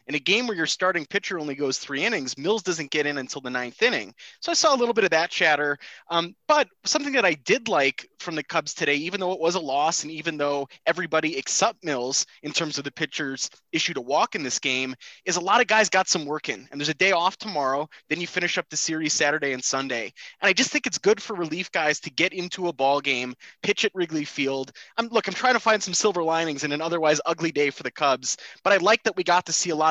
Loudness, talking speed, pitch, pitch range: -24 LUFS, 265 wpm, 165 Hz, 145-190 Hz